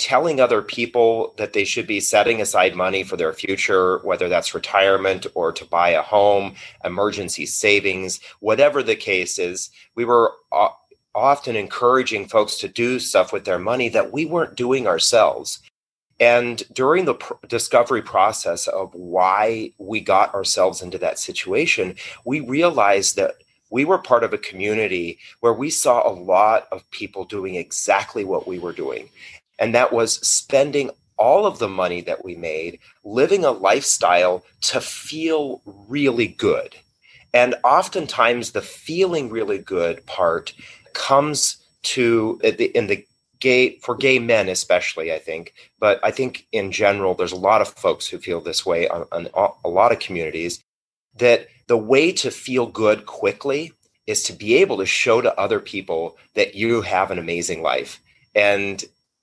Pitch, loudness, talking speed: 125 Hz, -19 LUFS, 160 wpm